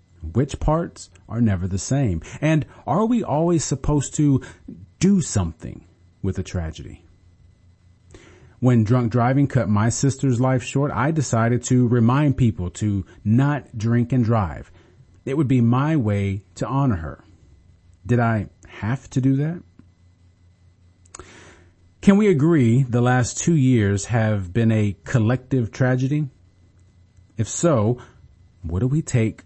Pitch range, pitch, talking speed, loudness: 90-130 Hz, 115 Hz, 135 wpm, -21 LUFS